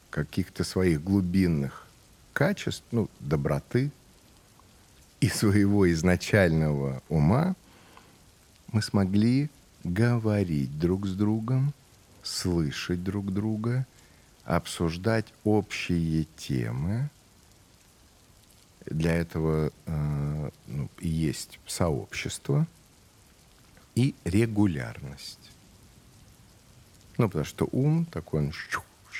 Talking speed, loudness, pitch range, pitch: 75 wpm, -28 LUFS, 80-110 Hz, 100 Hz